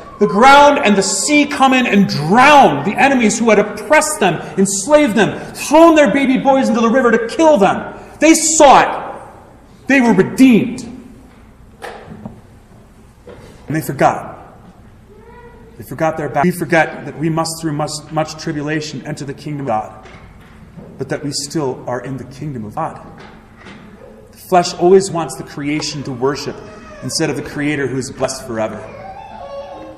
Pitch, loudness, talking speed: 165 Hz, -13 LUFS, 160 wpm